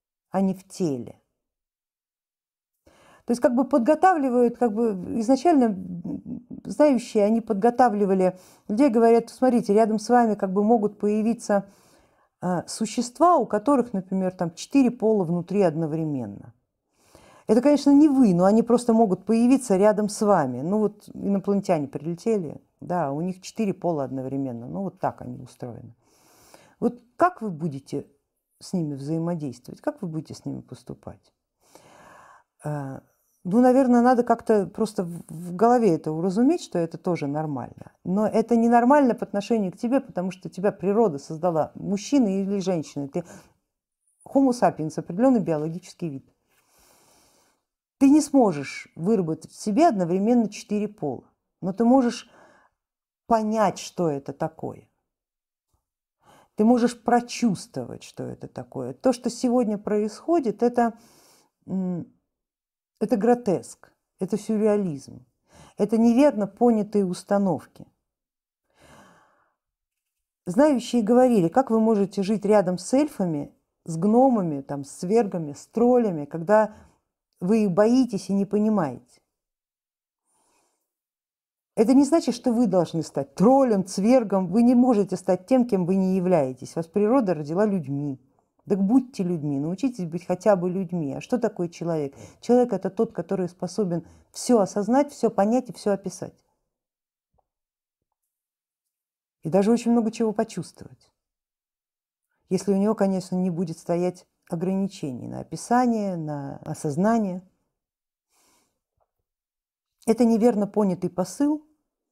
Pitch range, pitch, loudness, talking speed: 175-235 Hz, 200 Hz, -23 LUFS, 125 wpm